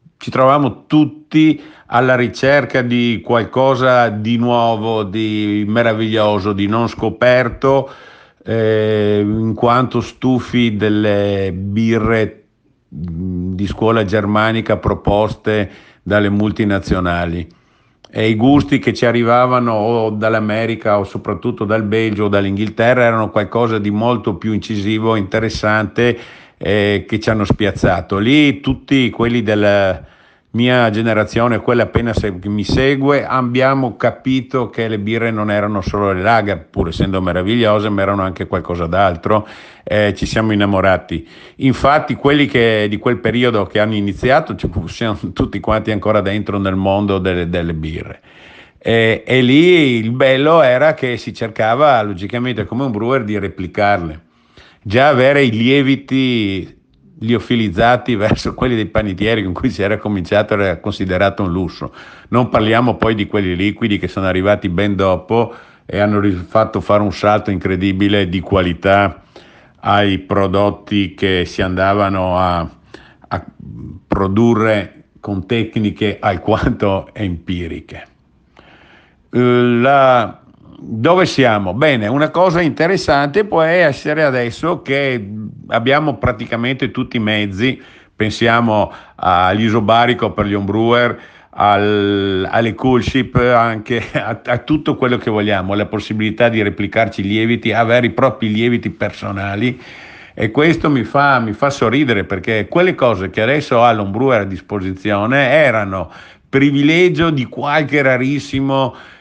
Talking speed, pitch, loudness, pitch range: 130 wpm, 110 Hz, -15 LUFS, 100-125 Hz